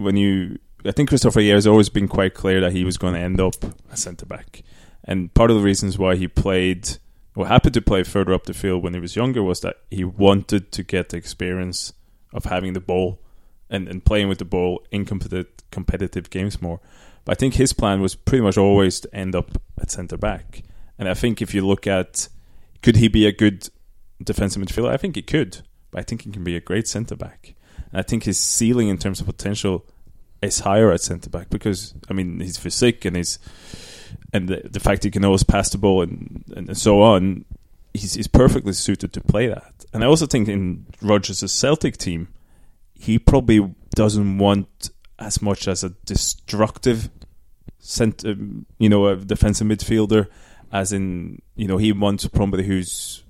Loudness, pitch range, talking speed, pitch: -20 LUFS, 90-105 Hz, 200 wpm, 95 Hz